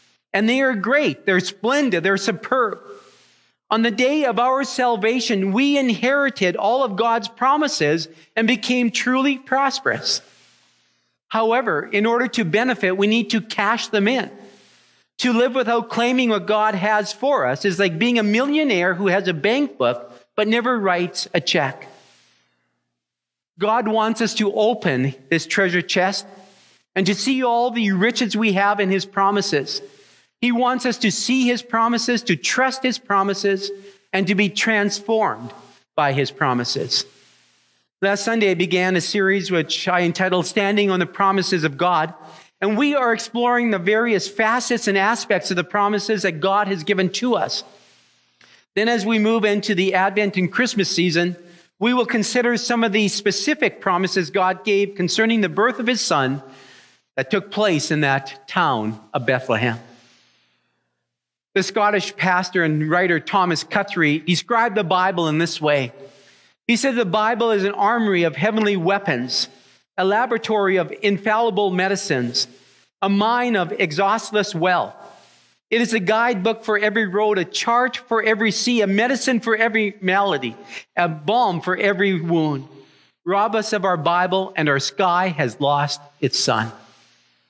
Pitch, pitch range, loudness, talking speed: 200 Hz, 175-230 Hz, -19 LUFS, 160 wpm